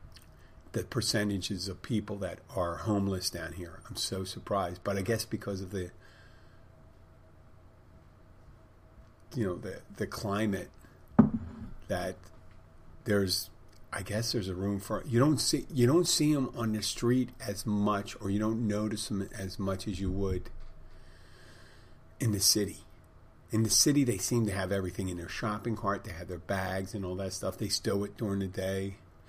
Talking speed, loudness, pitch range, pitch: 170 wpm, -32 LUFS, 90-110 Hz, 100 Hz